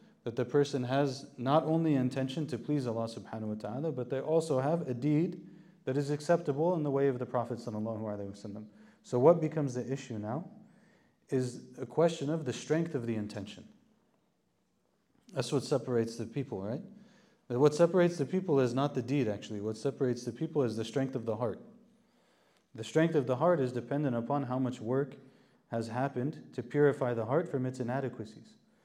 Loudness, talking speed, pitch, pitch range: -32 LUFS, 185 wpm, 135 Hz, 120-160 Hz